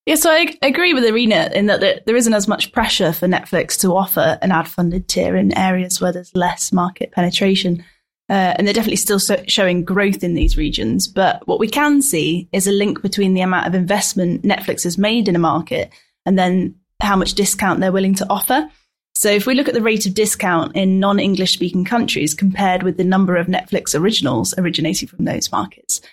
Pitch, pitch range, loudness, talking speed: 190 Hz, 180-210 Hz, -16 LUFS, 210 wpm